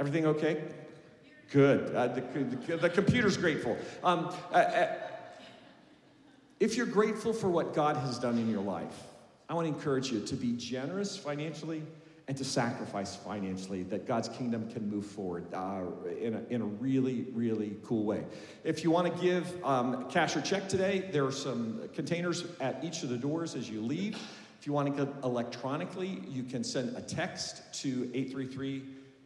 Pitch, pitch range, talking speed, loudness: 140 Hz, 120-170 Hz, 180 wpm, -33 LUFS